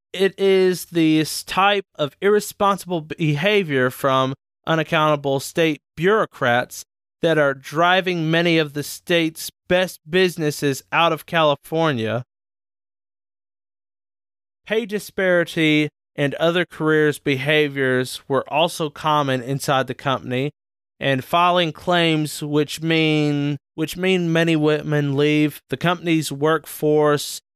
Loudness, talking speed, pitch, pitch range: -20 LUFS, 105 wpm, 150 Hz, 135-170 Hz